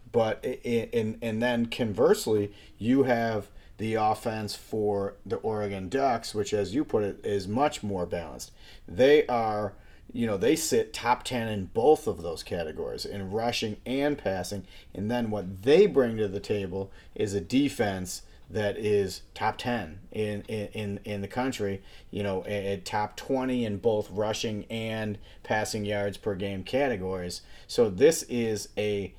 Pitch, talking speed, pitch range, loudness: 105 Hz, 160 wpm, 100-115 Hz, -28 LUFS